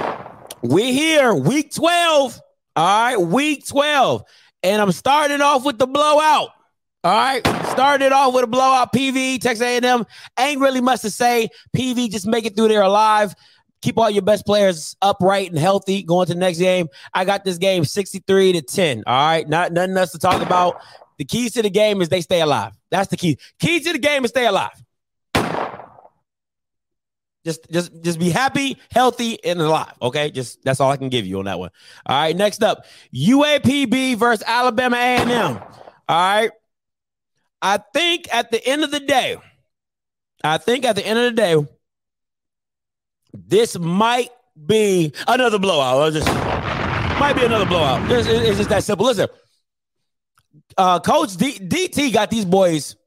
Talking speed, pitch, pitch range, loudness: 175 wpm, 215 Hz, 175-255 Hz, -18 LUFS